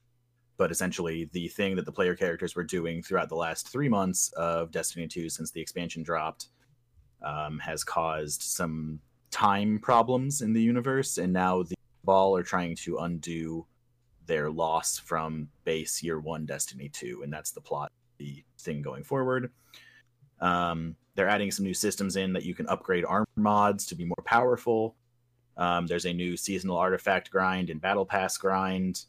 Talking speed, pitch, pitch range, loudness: 170 wpm, 90 Hz, 80-110 Hz, -29 LUFS